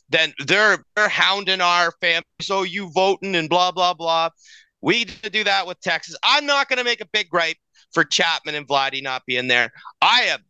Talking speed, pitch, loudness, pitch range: 200 wpm, 180 Hz, -19 LUFS, 165-200 Hz